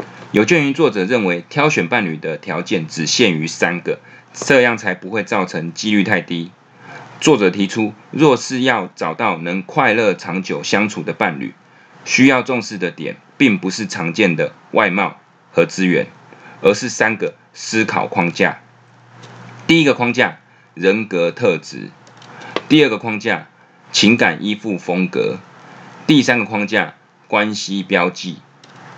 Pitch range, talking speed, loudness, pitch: 85-105 Hz, 215 characters per minute, -16 LUFS, 95 Hz